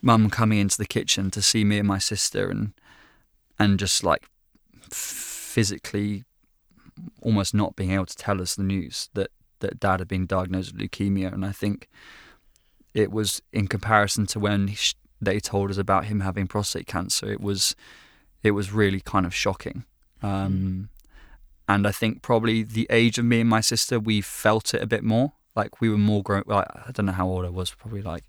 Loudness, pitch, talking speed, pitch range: -24 LUFS, 100 Hz, 195 wpm, 95-110 Hz